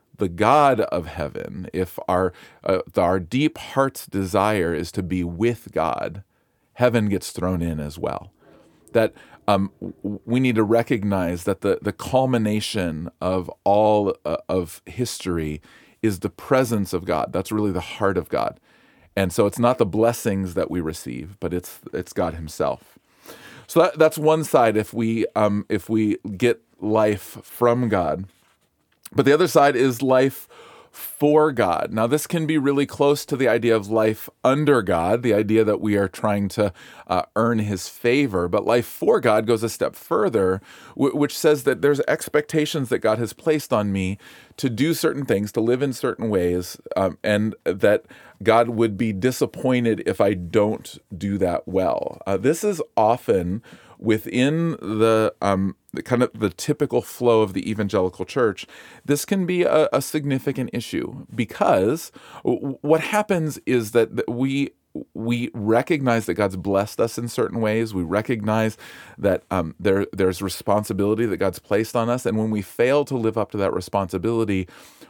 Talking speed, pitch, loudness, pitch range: 170 wpm, 110 Hz, -22 LUFS, 95-125 Hz